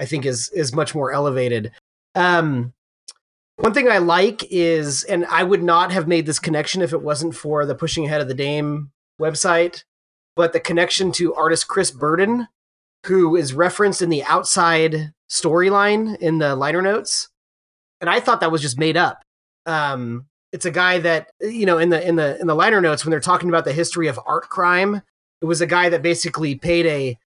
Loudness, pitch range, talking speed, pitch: -18 LUFS, 150-175 Hz, 200 wpm, 165 Hz